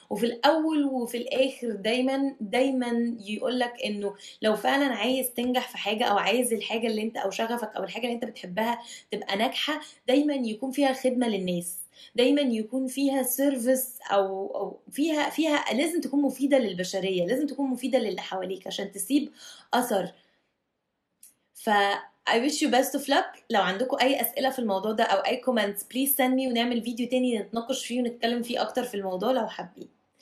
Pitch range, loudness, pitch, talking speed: 215-265 Hz, -27 LUFS, 245 Hz, 170 wpm